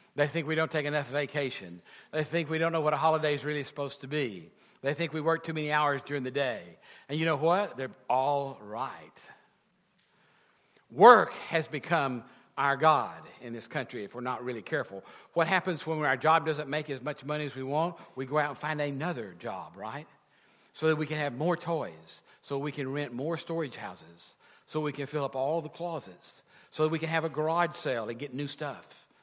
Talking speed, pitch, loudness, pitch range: 215 wpm, 150 Hz, -30 LUFS, 140-160 Hz